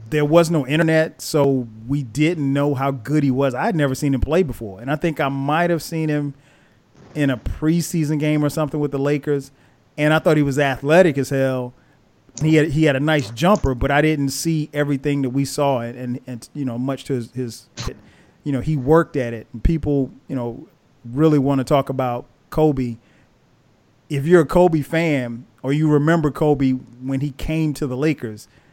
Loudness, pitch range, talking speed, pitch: -20 LUFS, 130-155 Hz, 205 wpm, 145 Hz